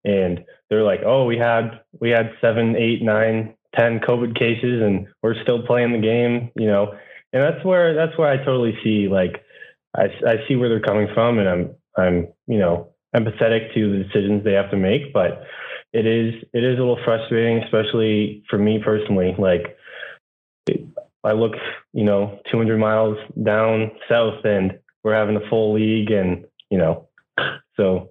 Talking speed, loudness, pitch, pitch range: 180 wpm, -20 LUFS, 110 Hz, 105-115 Hz